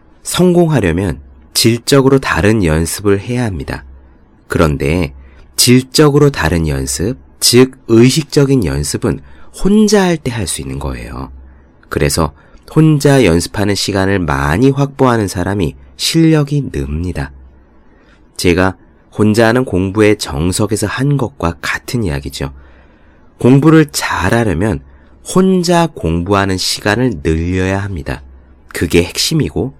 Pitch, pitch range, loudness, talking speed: 95 Hz, 75-130 Hz, -13 LUFS, 255 characters per minute